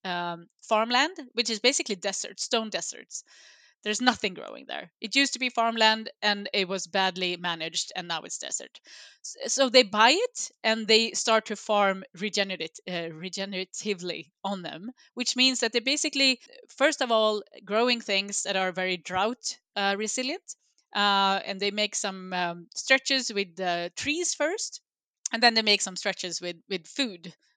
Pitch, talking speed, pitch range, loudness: 210 Hz, 165 wpm, 190-245 Hz, -26 LUFS